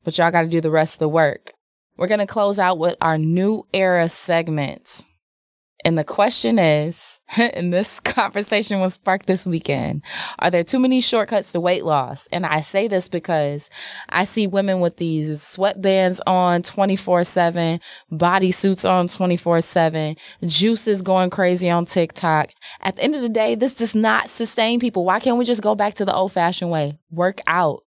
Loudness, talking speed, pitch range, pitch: -19 LUFS, 180 wpm, 165-200 Hz, 180 Hz